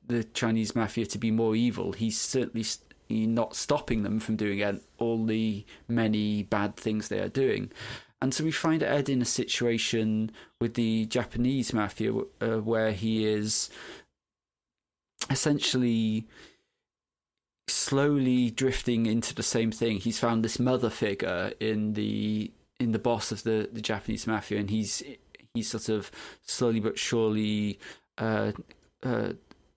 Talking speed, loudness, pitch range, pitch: 145 wpm, -29 LUFS, 105-120 Hz, 110 Hz